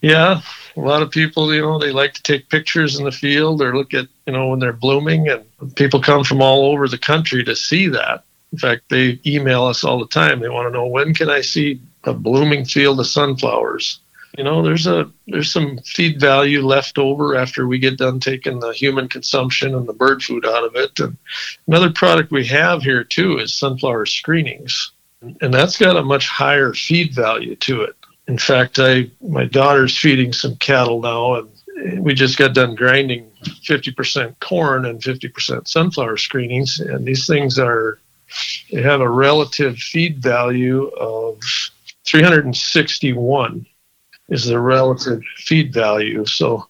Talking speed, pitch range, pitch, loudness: 180 wpm, 125-150 Hz, 135 Hz, -16 LUFS